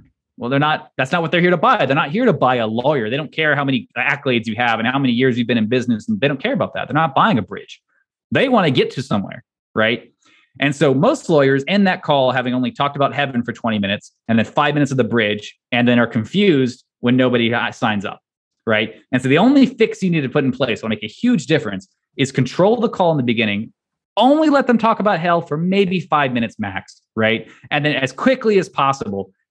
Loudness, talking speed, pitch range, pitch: -17 LUFS, 250 wpm, 120-170 Hz, 135 Hz